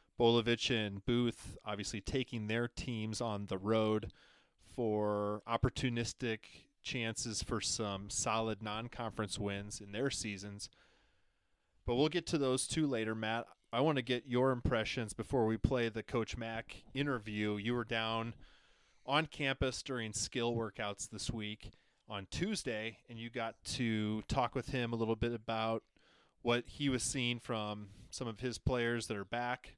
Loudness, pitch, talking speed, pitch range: -37 LUFS, 115 Hz, 155 wpm, 105-125 Hz